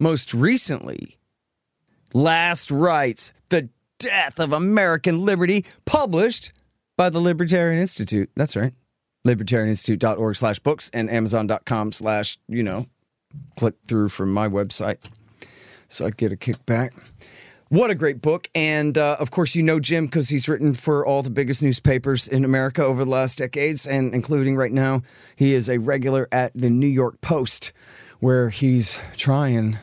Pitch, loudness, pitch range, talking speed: 130 Hz, -21 LUFS, 115-150 Hz, 150 wpm